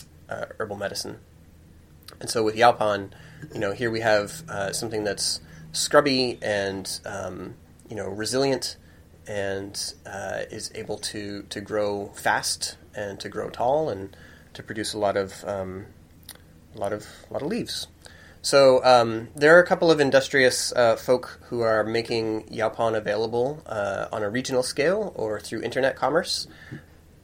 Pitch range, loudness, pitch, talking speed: 85-115 Hz, -24 LUFS, 100 Hz, 155 wpm